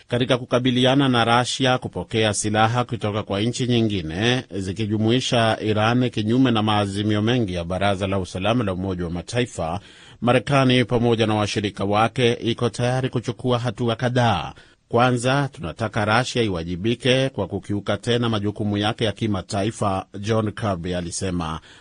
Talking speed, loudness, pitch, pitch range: 130 wpm, -21 LUFS, 110 Hz, 100-120 Hz